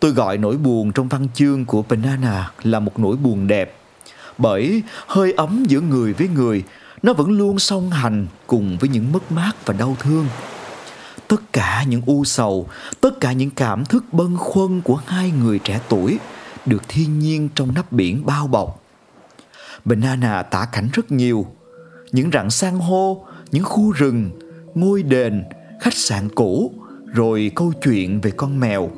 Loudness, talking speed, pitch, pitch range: -19 LUFS, 170 wpm, 135 Hz, 115-170 Hz